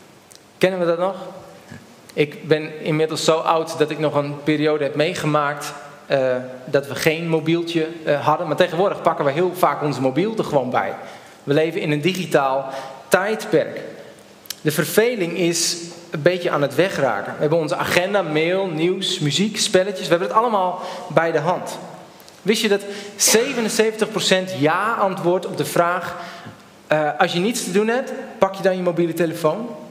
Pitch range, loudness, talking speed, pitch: 150-185 Hz, -20 LUFS, 170 wpm, 170 Hz